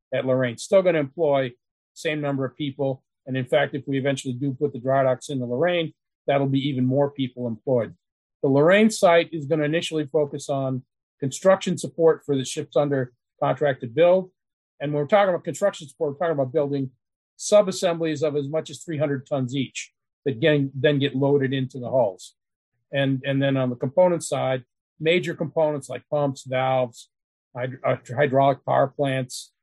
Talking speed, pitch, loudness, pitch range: 190 wpm, 140 Hz, -23 LUFS, 130-155 Hz